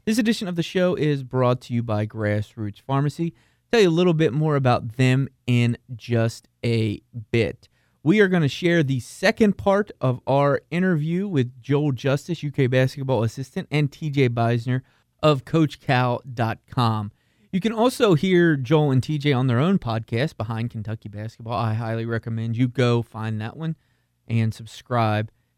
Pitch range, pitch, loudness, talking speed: 115-150 Hz, 130 Hz, -22 LUFS, 165 wpm